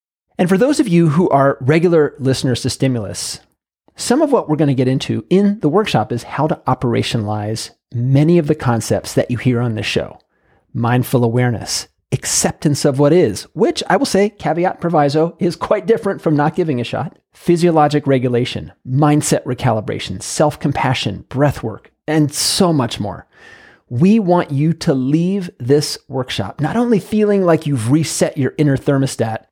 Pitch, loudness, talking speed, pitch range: 145 Hz, -16 LUFS, 170 wpm, 125-165 Hz